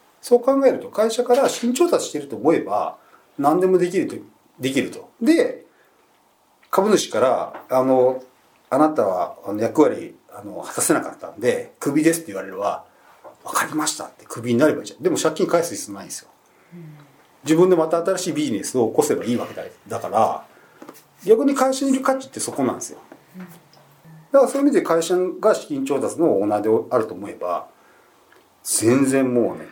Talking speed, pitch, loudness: 355 characters per minute, 185 Hz, -20 LUFS